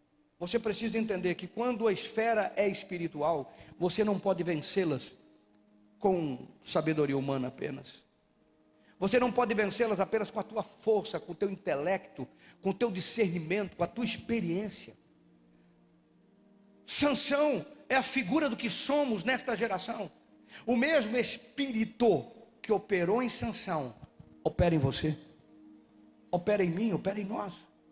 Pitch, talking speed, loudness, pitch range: 200 Hz, 135 wpm, -31 LUFS, 160-230 Hz